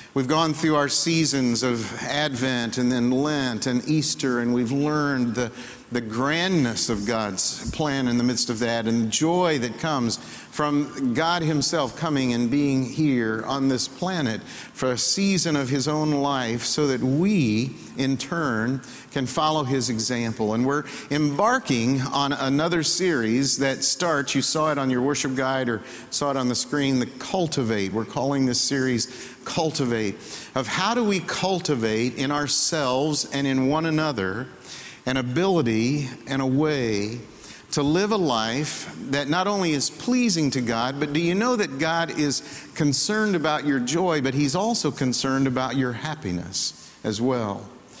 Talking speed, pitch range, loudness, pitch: 165 wpm, 125-155 Hz, -23 LUFS, 135 Hz